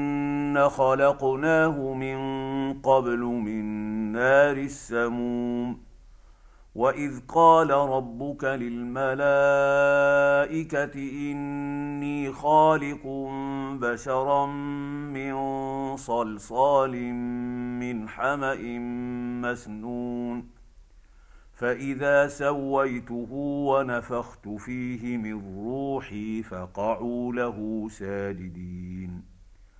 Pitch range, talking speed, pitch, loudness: 120-140 Hz, 55 wpm, 130 Hz, -26 LUFS